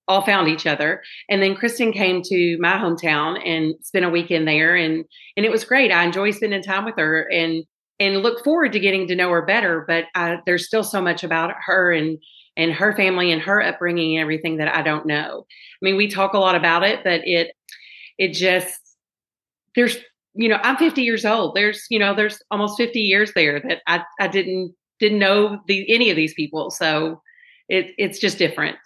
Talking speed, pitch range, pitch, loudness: 210 wpm, 165-210 Hz, 185 Hz, -19 LUFS